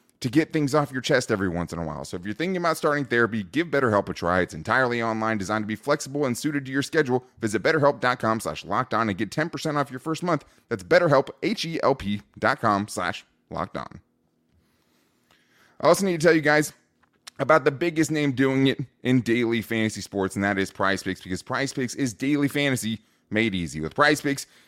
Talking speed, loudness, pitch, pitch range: 200 wpm, -24 LUFS, 120 Hz, 100-145 Hz